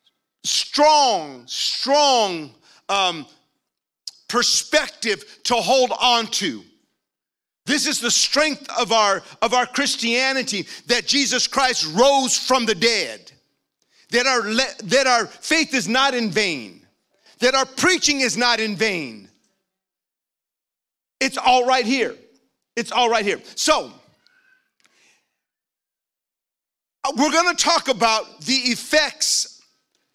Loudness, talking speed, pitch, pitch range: -19 LUFS, 115 wpm, 255 Hz, 230-280 Hz